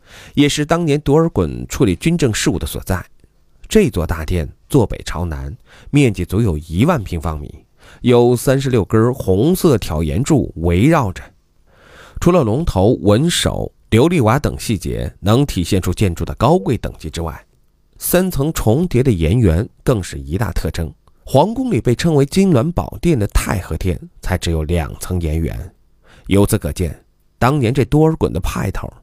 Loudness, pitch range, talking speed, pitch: -16 LUFS, 85-140 Hz, 245 characters per minute, 100 Hz